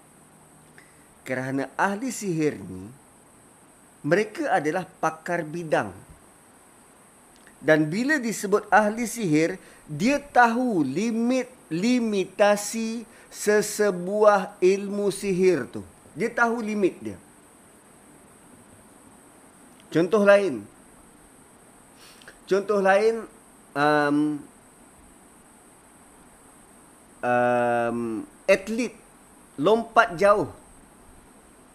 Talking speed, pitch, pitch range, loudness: 60 wpm, 195 Hz, 150-220 Hz, -23 LUFS